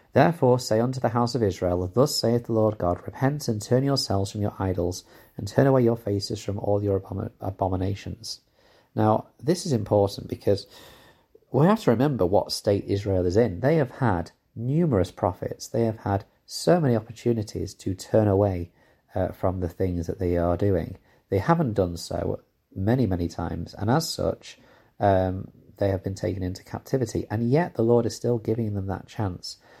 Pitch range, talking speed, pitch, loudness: 95-120 Hz, 185 wpm, 105 Hz, -25 LUFS